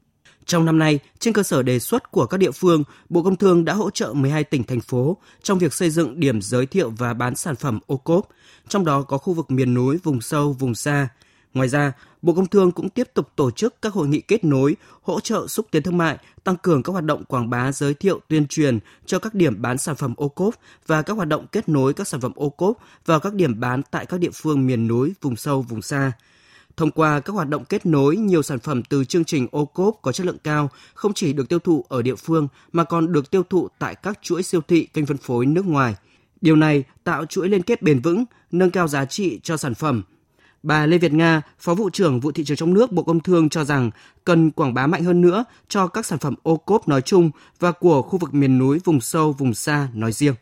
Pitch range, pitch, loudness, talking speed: 135-180 Hz, 155 Hz, -20 LUFS, 250 wpm